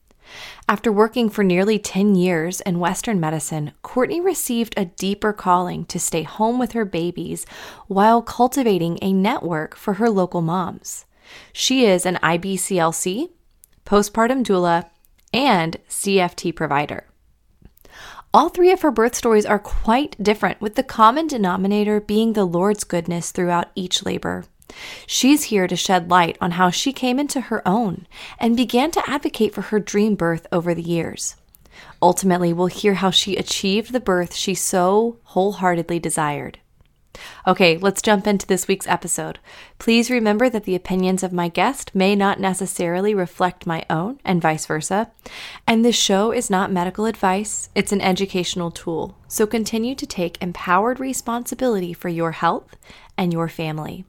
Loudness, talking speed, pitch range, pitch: -20 LUFS, 155 wpm, 175-225 Hz, 190 Hz